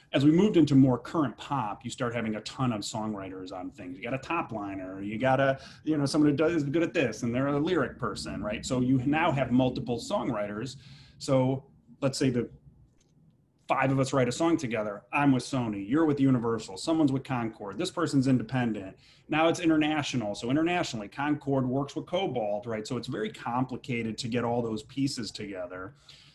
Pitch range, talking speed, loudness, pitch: 115-145 Hz, 200 wpm, -29 LUFS, 130 Hz